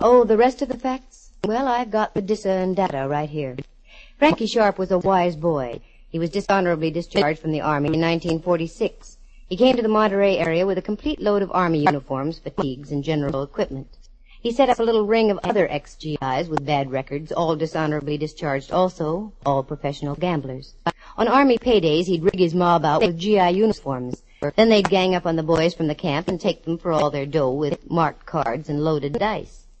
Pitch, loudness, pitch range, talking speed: 170 Hz, -21 LUFS, 150-205 Hz, 210 wpm